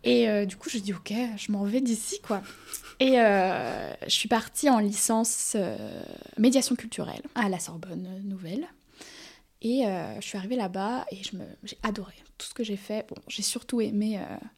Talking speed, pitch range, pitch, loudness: 200 wpm, 200-245 Hz, 215 Hz, -28 LUFS